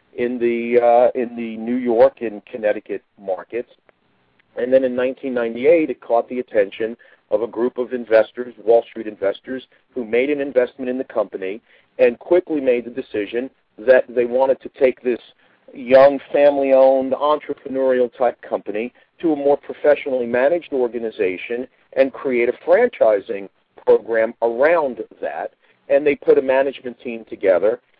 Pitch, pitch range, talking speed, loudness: 125 Hz, 120-135 Hz, 150 wpm, -19 LUFS